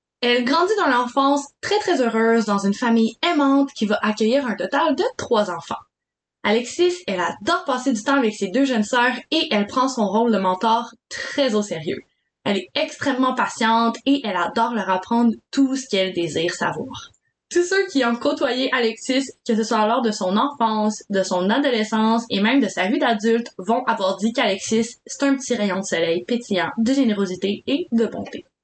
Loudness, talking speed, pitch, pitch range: -20 LUFS, 195 wpm, 235 Hz, 215-275 Hz